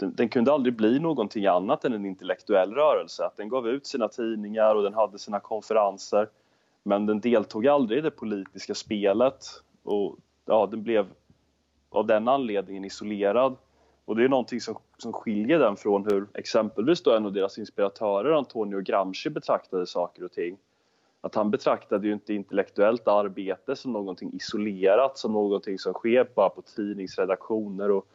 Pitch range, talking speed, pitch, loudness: 100-110 Hz, 160 wpm, 105 Hz, -26 LUFS